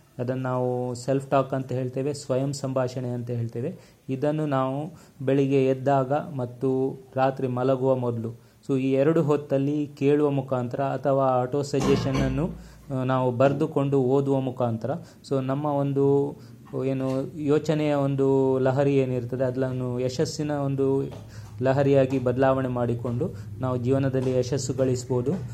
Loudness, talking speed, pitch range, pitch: -25 LUFS, 115 wpm, 130-140 Hz, 135 Hz